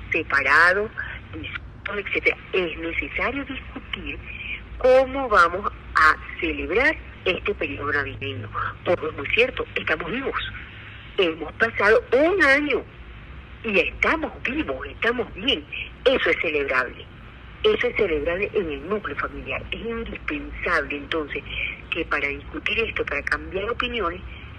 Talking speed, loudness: 115 wpm, -23 LUFS